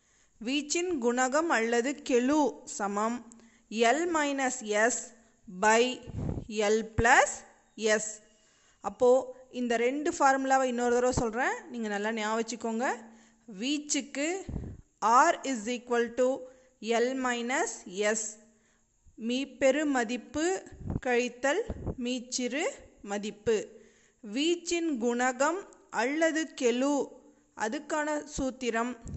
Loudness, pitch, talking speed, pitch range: -29 LUFS, 245 Hz, 85 wpm, 225-275 Hz